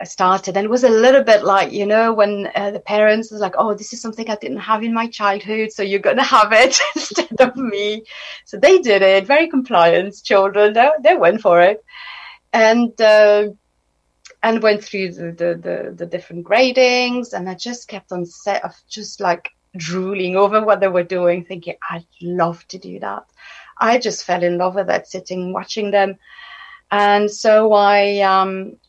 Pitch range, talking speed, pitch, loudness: 185-225 Hz, 190 wpm, 205 Hz, -15 LUFS